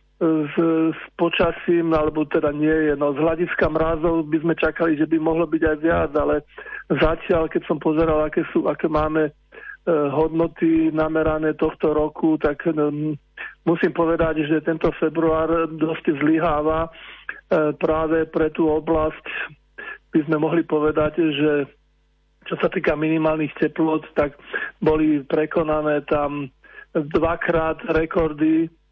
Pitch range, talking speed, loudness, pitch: 155-165 Hz, 135 wpm, -21 LUFS, 160 Hz